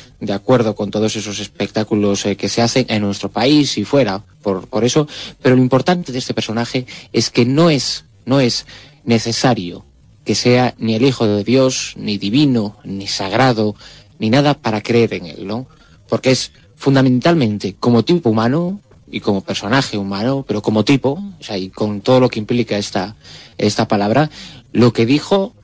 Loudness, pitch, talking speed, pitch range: -16 LUFS, 115 Hz, 180 wpm, 105-130 Hz